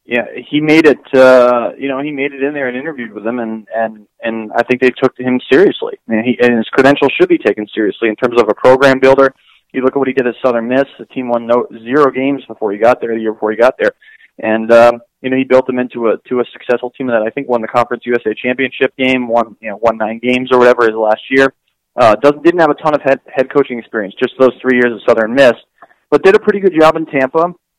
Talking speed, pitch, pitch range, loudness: 270 wpm, 125 Hz, 120-140 Hz, -12 LUFS